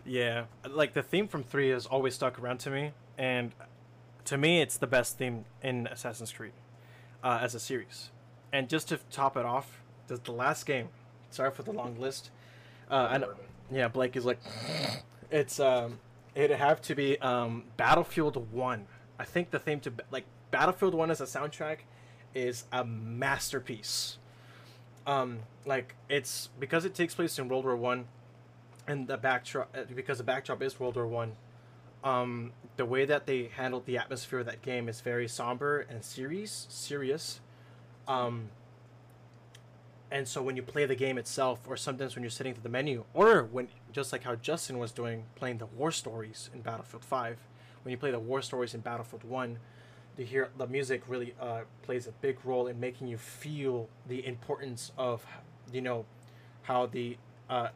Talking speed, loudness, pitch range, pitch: 175 wpm, -33 LUFS, 120-135 Hz, 125 Hz